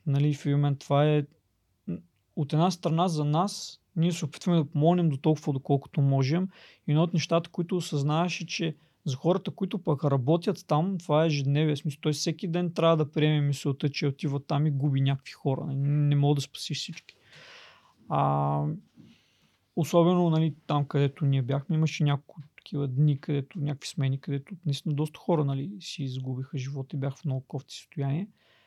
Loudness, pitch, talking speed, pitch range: -28 LUFS, 150 Hz, 175 wpm, 140-165 Hz